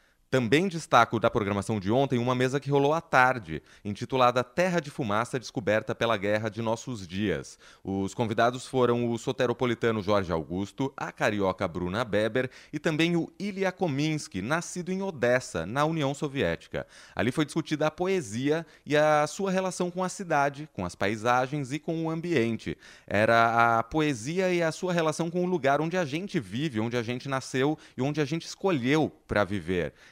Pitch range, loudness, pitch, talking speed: 115-160 Hz, -28 LUFS, 130 Hz, 175 wpm